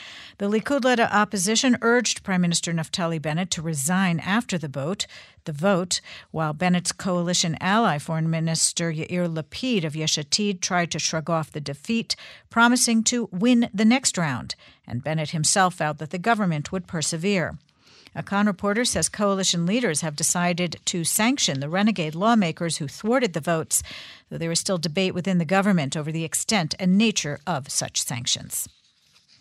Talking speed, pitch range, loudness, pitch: 160 wpm, 160-205 Hz, -23 LUFS, 180 Hz